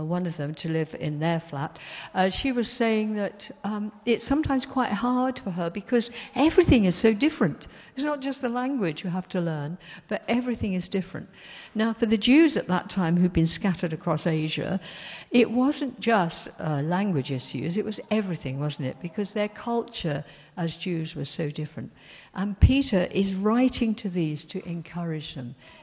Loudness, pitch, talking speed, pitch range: -26 LUFS, 190 Hz, 180 wpm, 165-230 Hz